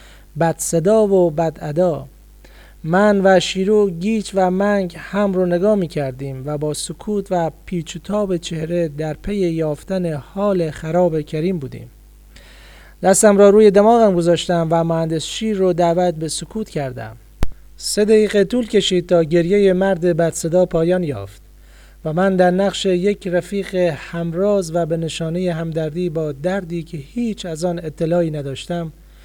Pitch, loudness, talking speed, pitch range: 175 Hz, -18 LUFS, 150 wpm, 160-195 Hz